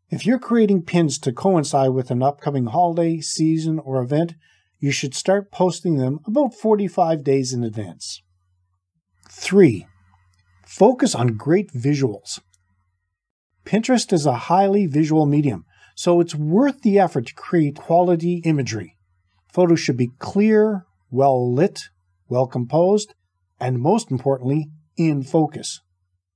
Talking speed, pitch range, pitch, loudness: 125 wpm, 110-175 Hz, 145 Hz, -19 LUFS